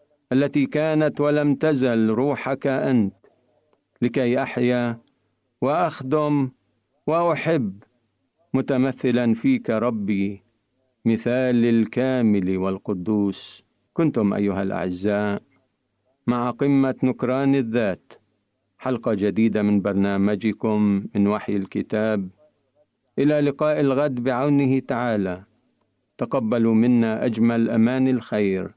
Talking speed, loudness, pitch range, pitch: 85 wpm, -22 LUFS, 105-135 Hz, 120 Hz